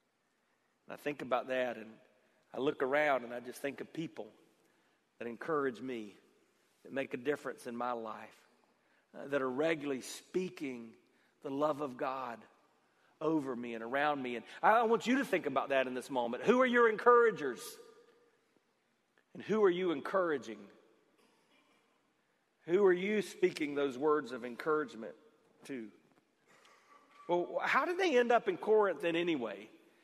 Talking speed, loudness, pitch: 150 wpm, -34 LUFS, 150 Hz